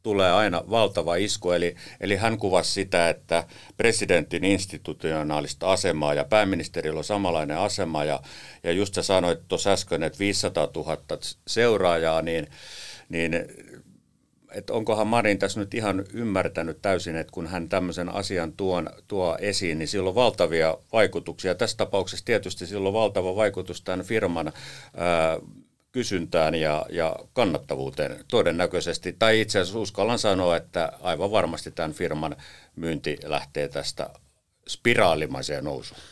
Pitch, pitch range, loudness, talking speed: 90 Hz, 80-100 Hz, -25 LUFS, 135 wpm